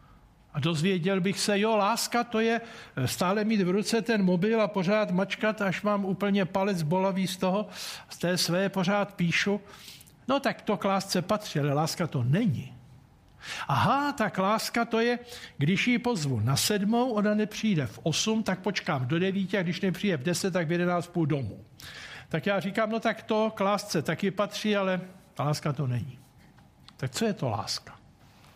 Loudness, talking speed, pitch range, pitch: -28 LUFS, 185 wpm, 175-215 Hz, 195 Hz